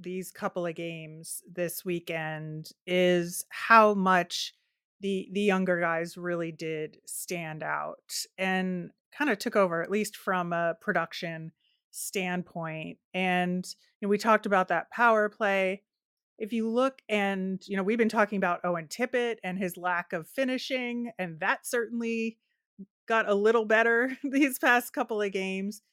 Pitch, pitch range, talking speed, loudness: 195 Hz, 175-225 Hz, 155 wpm, -28 LUFS